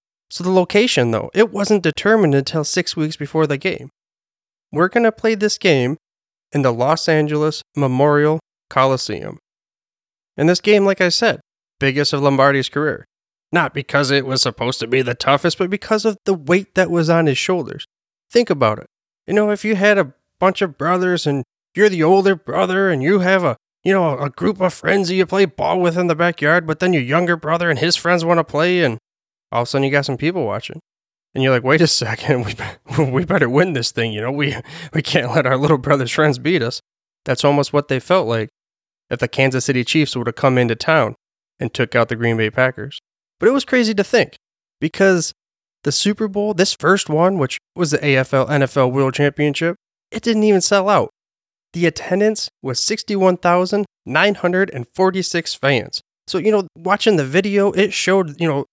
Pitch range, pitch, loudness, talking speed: 135-190 Hz, 165 Hz, -17 LUFS, 200 wpm